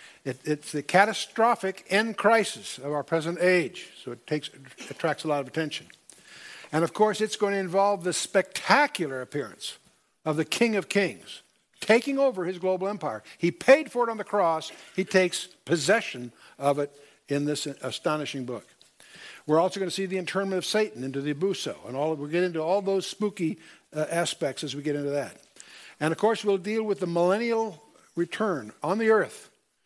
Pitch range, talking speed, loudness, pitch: 150-200 Hz, 190 wpm, -27 LUFS, 180 Hz